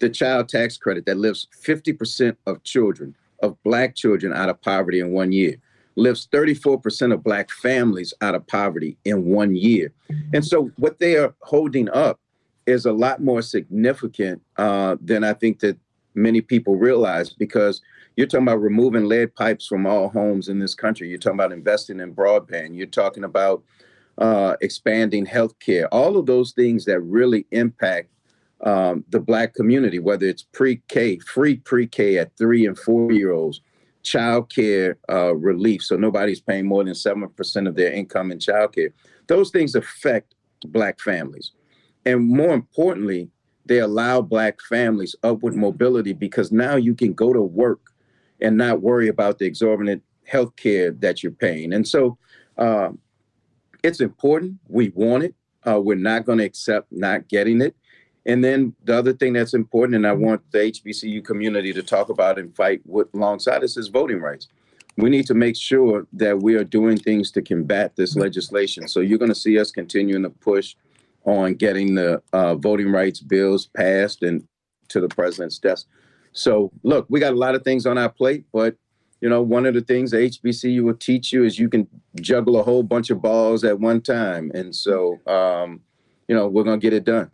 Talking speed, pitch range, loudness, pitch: 185 wpm, 100-120 Hz, -20 LUFS, 110 Hz